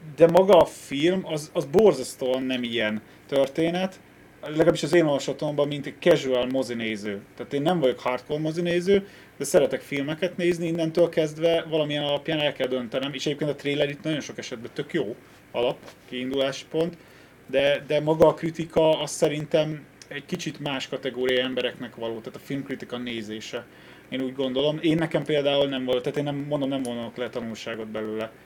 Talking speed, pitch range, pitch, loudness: 175 wpm, 130-160 Hz, 145 Hz, -25 LUFS